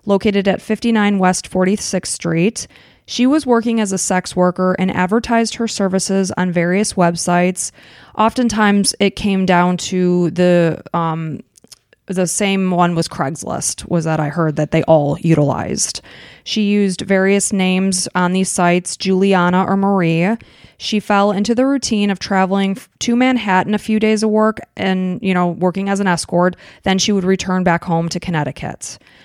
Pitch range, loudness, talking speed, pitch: 175-205 Hz, -16 LUFS, 165 wpm, 190 Hz